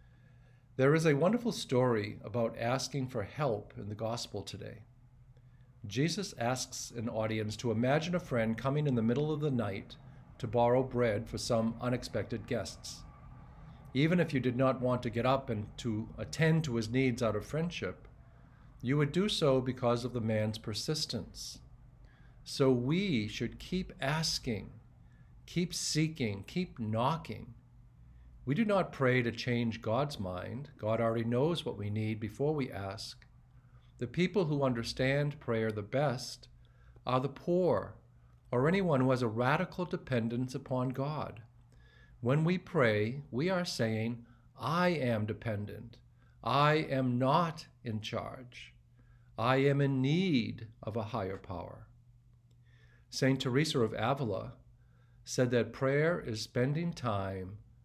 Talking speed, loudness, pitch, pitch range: 145 wpm, -33 LUFS, 125 Hz, 115-135 Hz